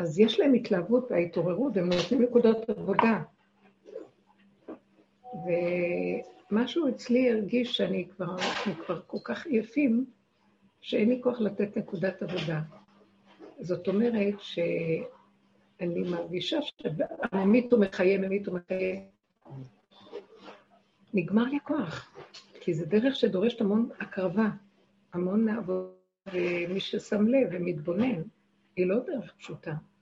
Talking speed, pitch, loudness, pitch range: 100 wpm, 200 Hz, -29 LUFS, 180-235 Hz